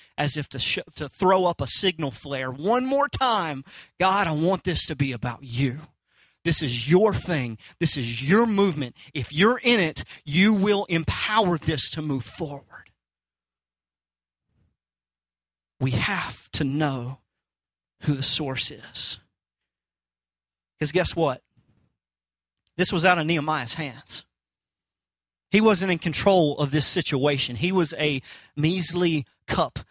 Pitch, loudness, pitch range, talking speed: 145 Hz, -23 LUFS, 110-175 Hz, 140 wpm